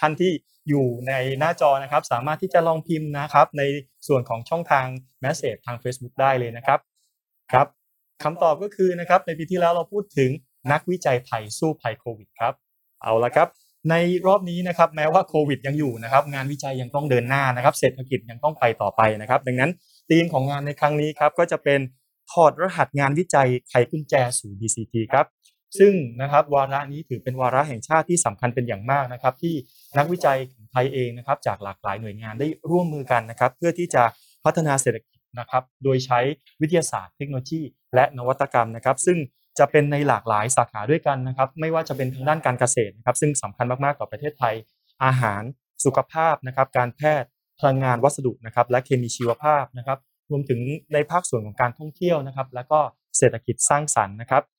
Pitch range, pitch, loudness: 125-155 Hz, 135 Hz, -22 LUFS